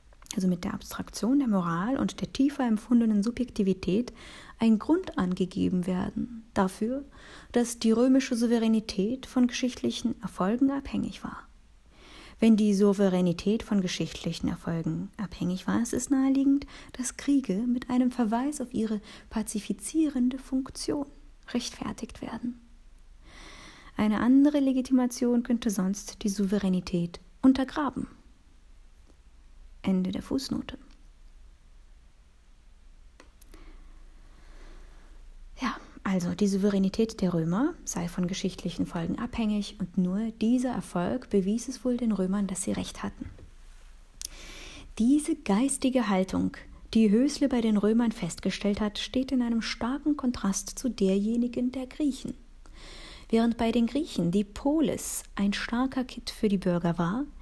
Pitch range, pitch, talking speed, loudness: 190-255 Hz, 225 Hz, 120 wpm, -28 LUFS